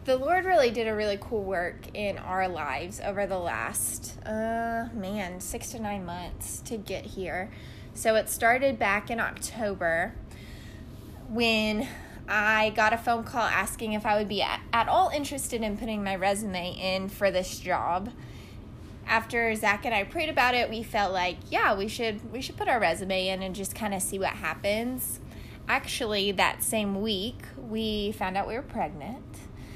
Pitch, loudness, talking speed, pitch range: 210 Hz, -28 LUFS, 175 wpm, 195-230 Hz